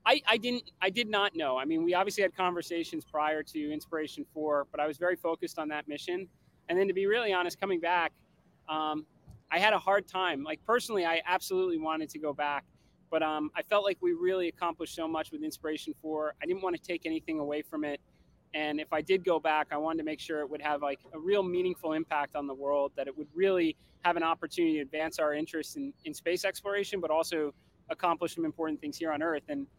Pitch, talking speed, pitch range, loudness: 165 Hz, 235 wpm, 155-185 Hz, -32 LUFS